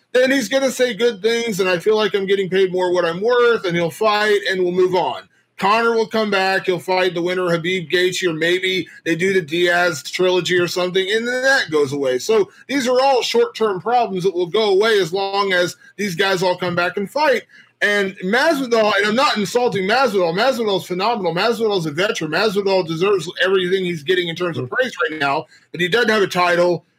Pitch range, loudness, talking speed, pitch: 180-225 Hz, -18 LUFS, 225 wpm, 195 Hz